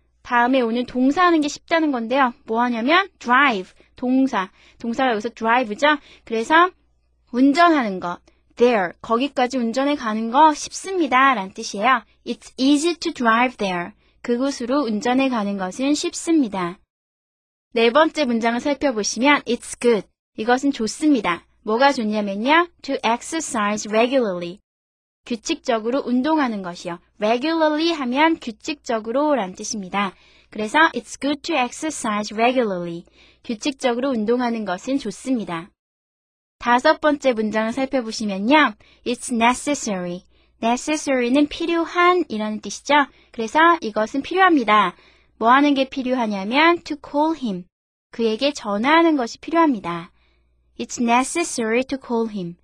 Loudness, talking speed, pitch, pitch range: -20 LUFS, 390 characters per minute, 250 Hz, 220-290 Hz